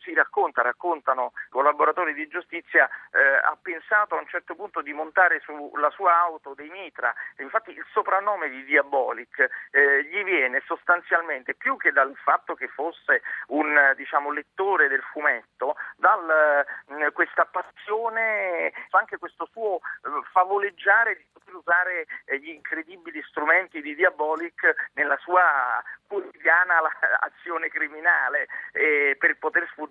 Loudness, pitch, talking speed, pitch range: -23 LUFS, 175 Hz, 130 wpm, 155-220 Hz